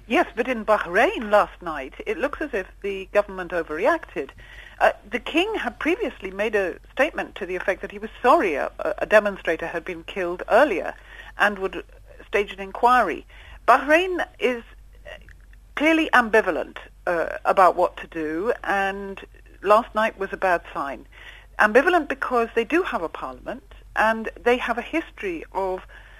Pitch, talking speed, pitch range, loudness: 220 Hz, 160 wpm, 195-295 Hz, -22 LUFS